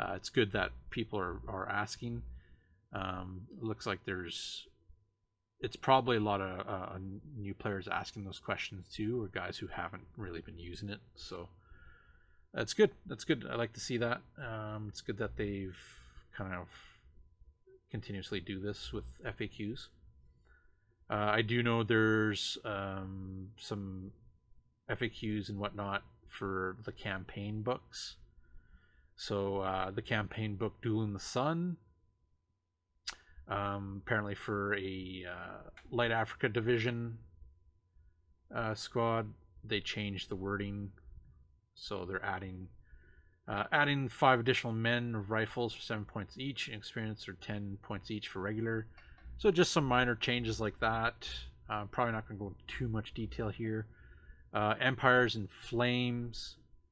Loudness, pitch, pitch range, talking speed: -36 LUFS, 105 Hz, 95-115 Hz, 140 wpm